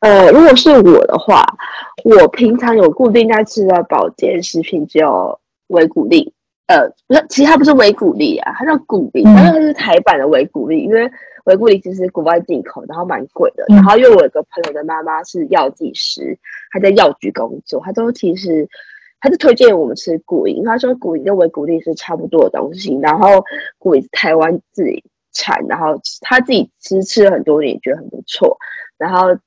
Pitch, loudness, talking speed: 230 Hz, -11 LUFS, 295 characters per minute